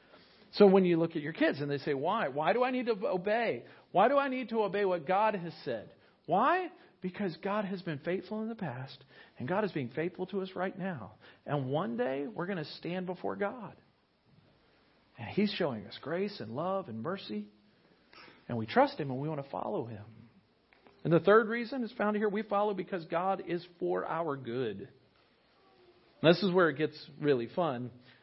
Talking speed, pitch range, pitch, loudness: 205 wpm, 145-200 Hz, 180 Hz, -32 LUFS